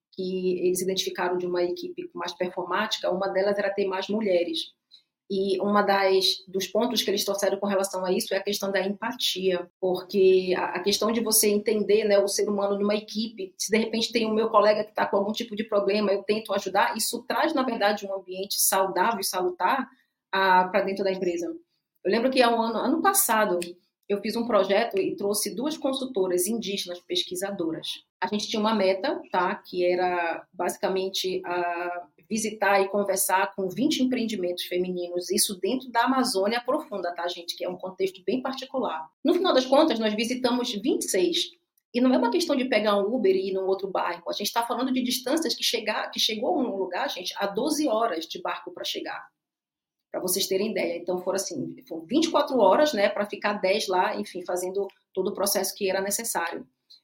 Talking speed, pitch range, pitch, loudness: 200 wpm, 185-230 Hz, 200 Hz, -25 LUFS